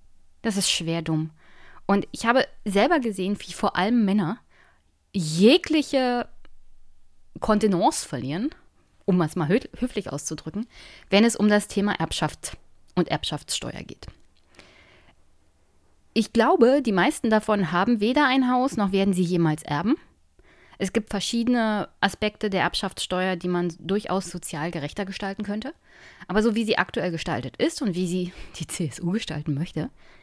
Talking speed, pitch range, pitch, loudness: 140 wpm, 165-220 Hz, 195 Hz, -24 LUFS